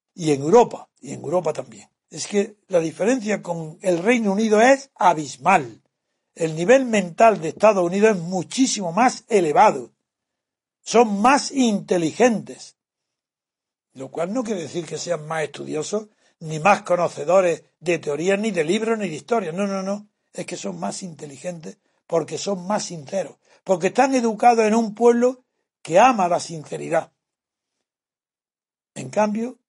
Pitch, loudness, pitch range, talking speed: 195 Hz, -20 LUFS, 170-230 Hz, 150 wpm